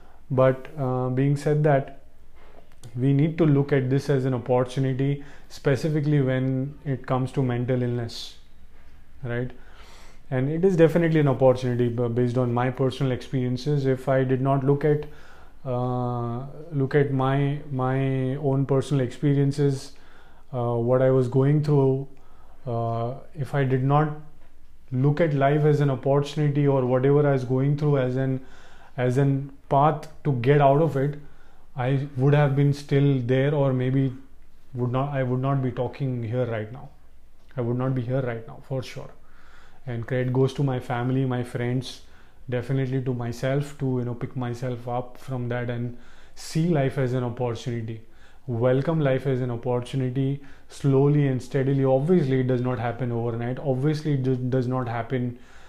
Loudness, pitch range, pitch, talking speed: -24 LUFS, 125-140 Hz, 130 Hz, 165 wpm